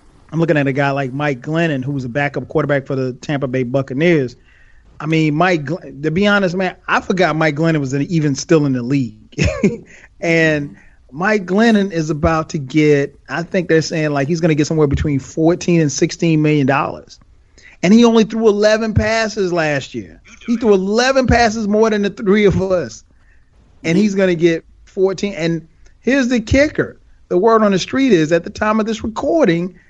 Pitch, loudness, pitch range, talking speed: 165 Hz, -16 LUFS, 145-200 Hz, 195 wpm